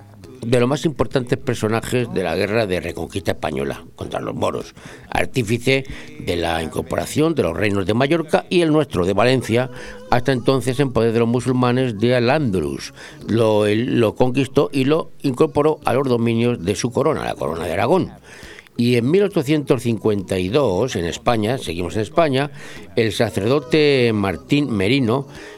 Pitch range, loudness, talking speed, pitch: 105-140 Hz, -19 LUFS, 150 wpm, 120 Hz